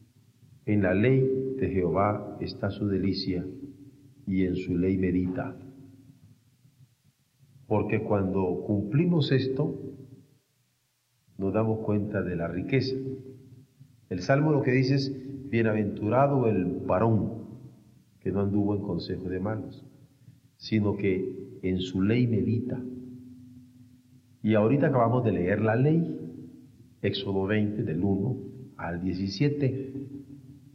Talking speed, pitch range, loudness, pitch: 115 wpm, 100-135 Hz, -28 LUFS, 120 Hz